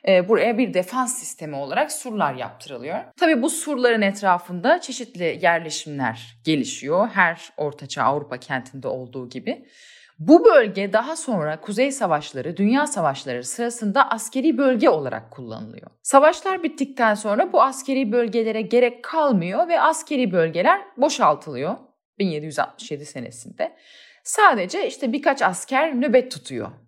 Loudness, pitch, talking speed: -21 LUFS, 230 Hz, 120 wpm